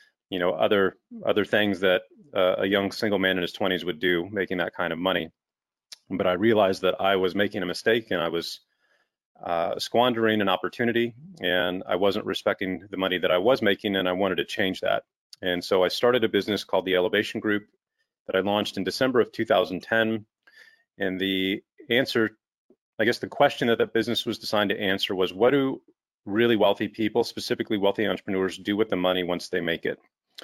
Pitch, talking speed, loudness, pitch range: 100 Hz, 200 wpm, -25 LUFS, 95-115 Hz